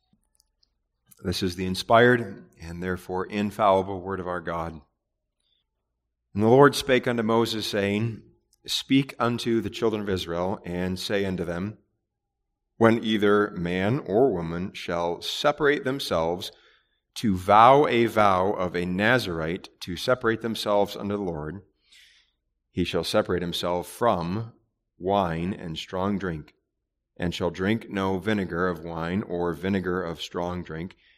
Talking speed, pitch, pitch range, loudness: 135 wpm, 95 Hz, 90-110 Hz, -25 LUFS